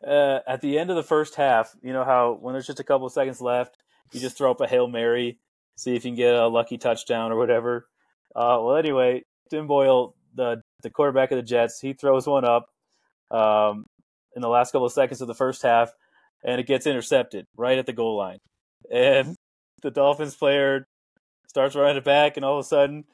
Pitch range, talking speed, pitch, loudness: 120-140 Hz, 220 wpm, 130 Hz, -23 LUFS